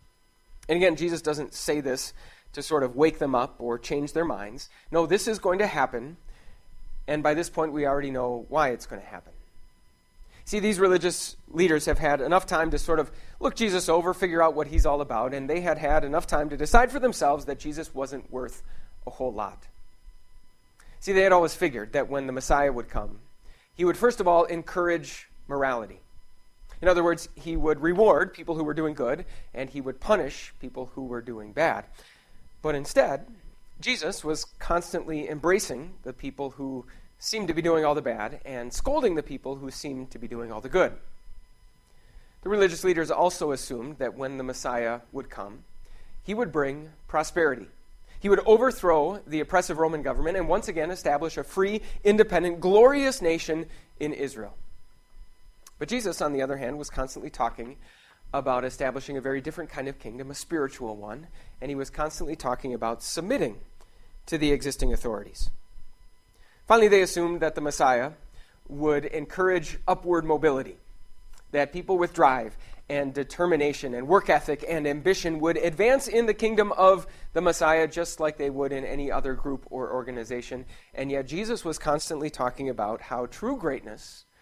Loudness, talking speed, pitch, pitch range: -26 LUFS, 180 wpm, 150 Hz, 130-170 Hz